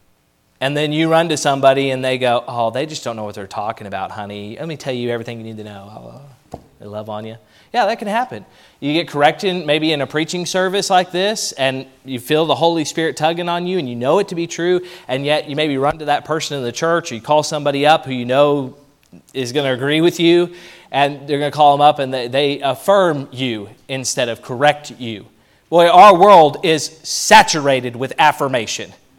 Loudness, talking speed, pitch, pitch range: -16 LUFS, 225 wpm, 145 Hz, 125-160 Hz